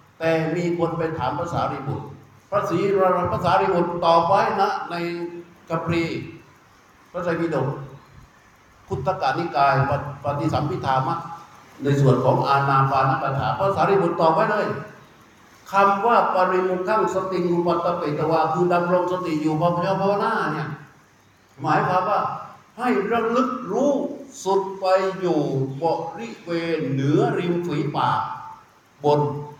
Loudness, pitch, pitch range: -22 LUFS, 170 Hz, 145-185 Hz